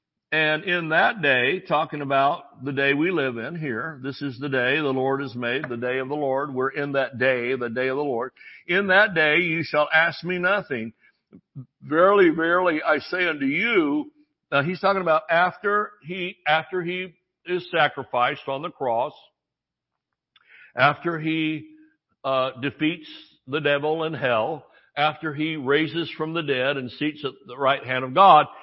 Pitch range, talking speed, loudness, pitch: 135-175 Hz, 175 wpm, -23 LUFS, 155 Hz